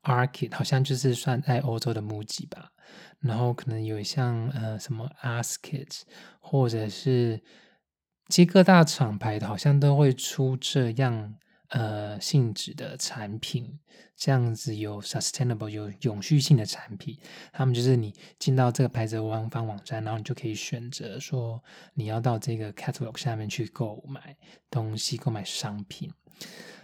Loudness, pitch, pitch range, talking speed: -27 LUFS, 125 Hz, 110-140 Hz, 275 characters per minute